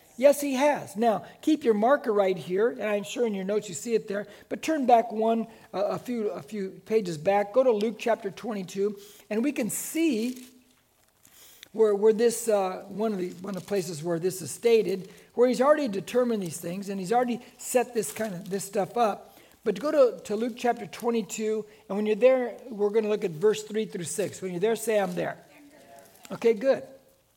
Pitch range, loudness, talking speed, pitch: 200-240 Hz, -27 LUFS, 215 wpm, 220 Hz